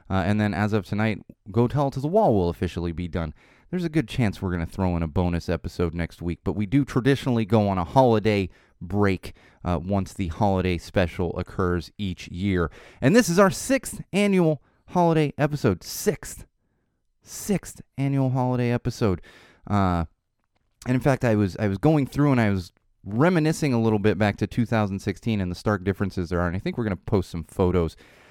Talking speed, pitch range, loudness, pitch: 200 wpm, 90-125 Hz, -24 LUFS, 105 Hz